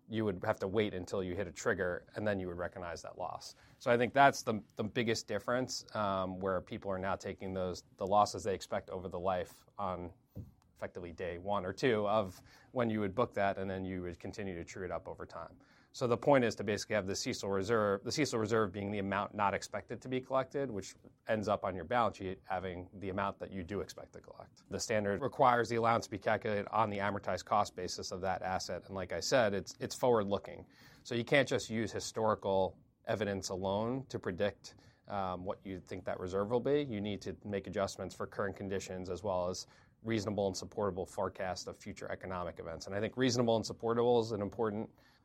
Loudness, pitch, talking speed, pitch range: -36 LUFS, 105 Hz, 225 wpm, 95-120 Hz